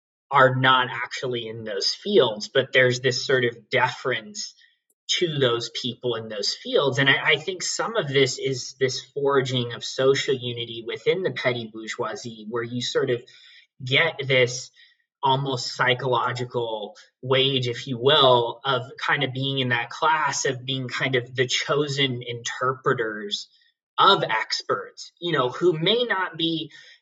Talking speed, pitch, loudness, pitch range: 155 wpm, 130 Hz, -23 LUFS, 125-155 Hz